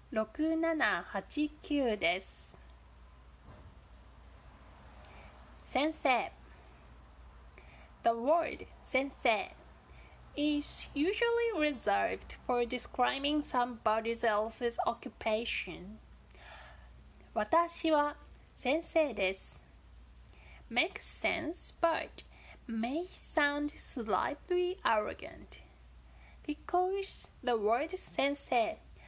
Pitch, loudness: 230 Hz, -33 LUFS